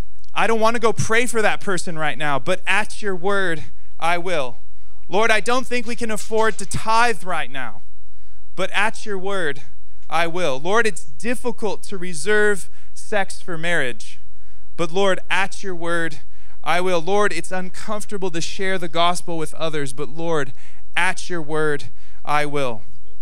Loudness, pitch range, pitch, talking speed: -22 LUFS, 130-200 Hz, 170 Hz, 170 wpm